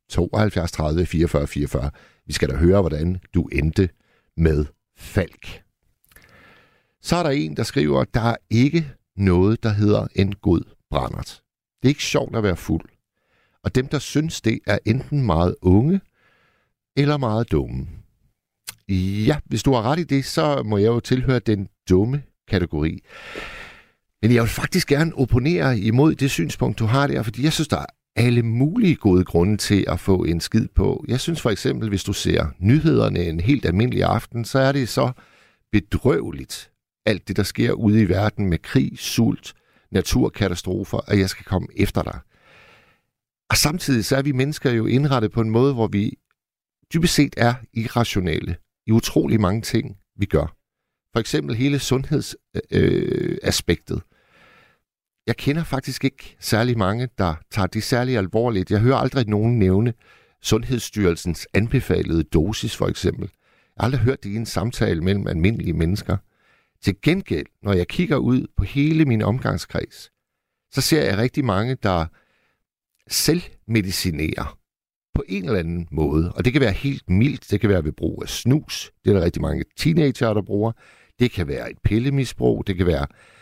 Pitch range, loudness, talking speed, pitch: 95-130 Hz, -21 LUFS, 170 wpm, 110 Hz